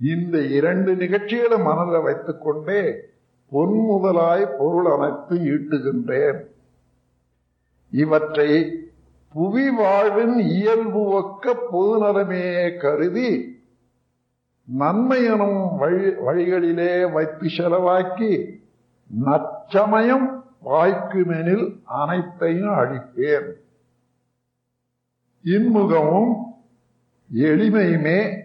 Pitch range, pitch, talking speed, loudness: 145-205 Hz, 175 Hz, 60 wpm, -20 LUFS